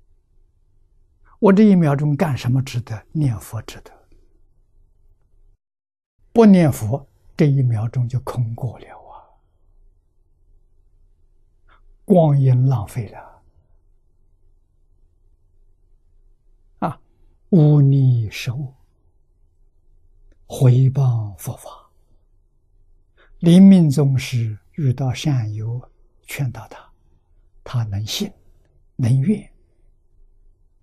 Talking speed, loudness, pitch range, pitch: 105 characters per minute, -18 LUFS, 85-130 Hz, 100 Hz